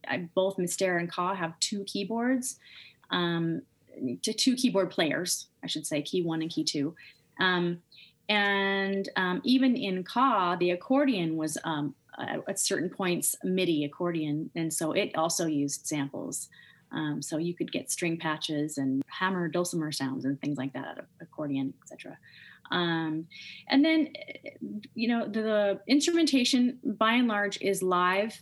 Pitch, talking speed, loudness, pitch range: 180 Hz, 160 wpm, -29 LUFS, 160-215 Hz